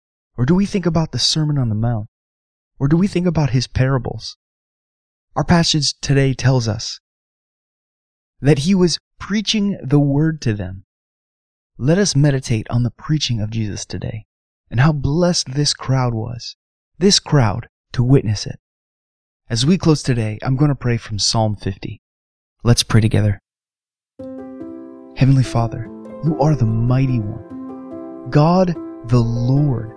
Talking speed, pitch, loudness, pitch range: 150 wpm, 125 Hz, -18 LUFS, 105-145 Hz